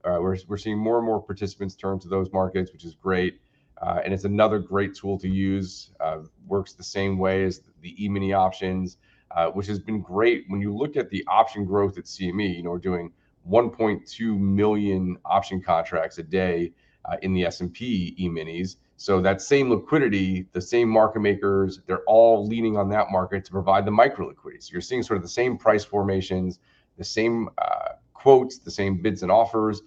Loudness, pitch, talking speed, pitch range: -24 LUFS, 95 Hz, 195 wpm, 95-105 Hz